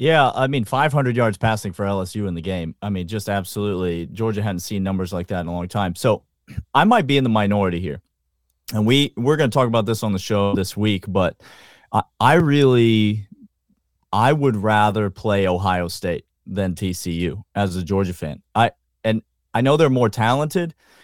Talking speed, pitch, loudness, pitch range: 195 wpm, 105 Hz, -20 LUFS, 95-120 Hz